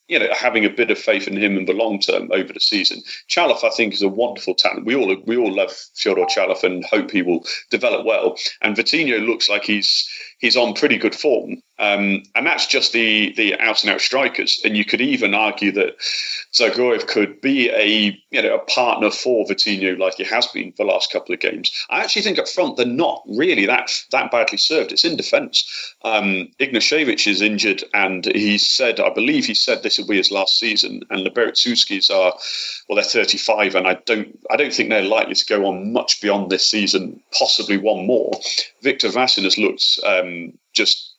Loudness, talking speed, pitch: -17 LUFS, 215 wpm, 110 Hz